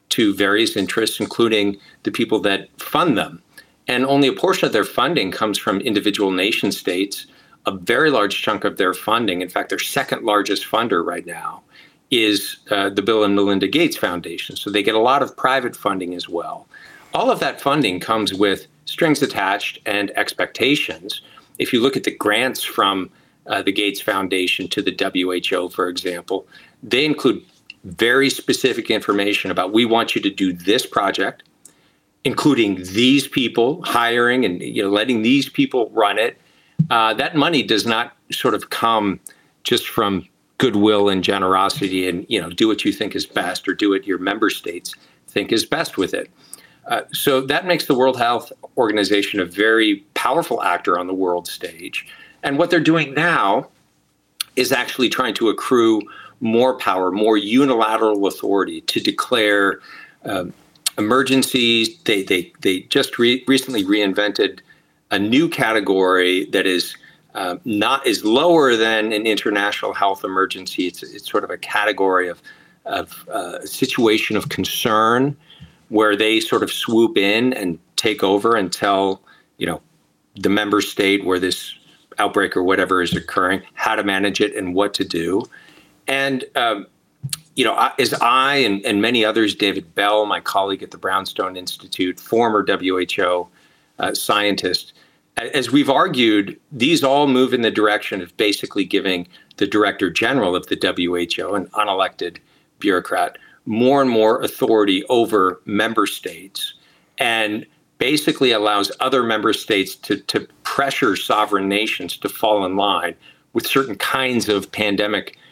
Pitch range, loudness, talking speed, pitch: 100-120 Hz, -18 LUFS, 160 wpm, 105 Hz